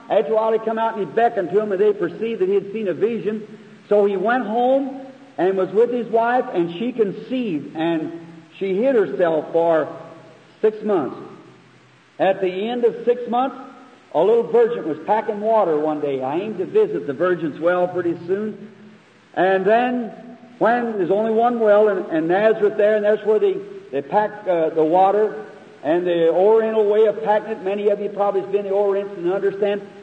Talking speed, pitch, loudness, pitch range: 190 wpm, 210 Hz, -20 LUFS, 185-230 Hz